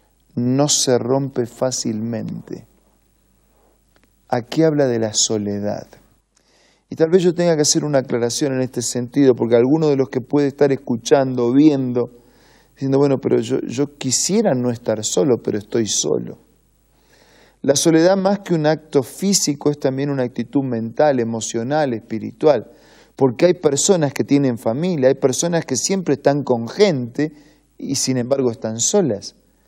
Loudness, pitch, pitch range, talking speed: -18 LUFS, 135 Hz, 120-150 Hz, 150 wpm